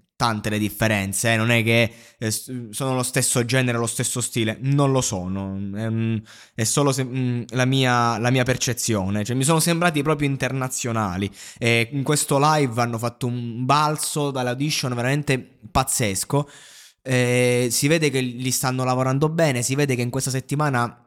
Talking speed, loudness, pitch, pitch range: 155 wpm, -21 LUFS, 125 Hz, 115-135 Hz